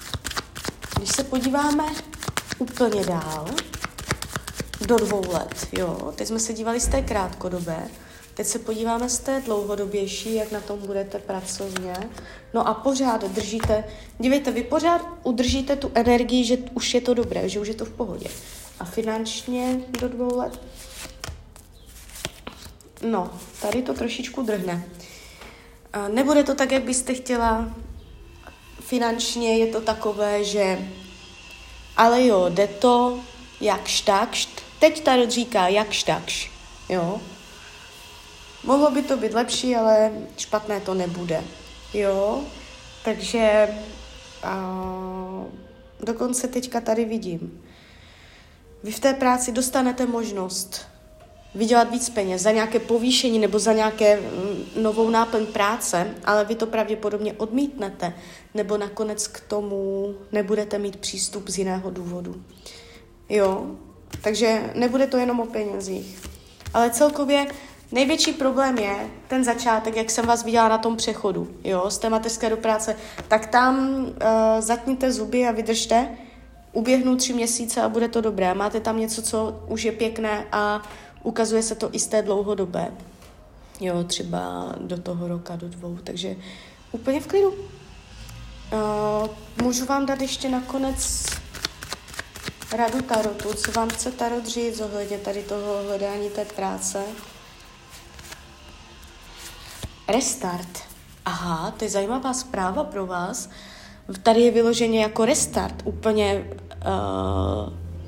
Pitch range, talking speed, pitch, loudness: 195-240 Hz, 130 wpm, 220 Hz, -23 LUFS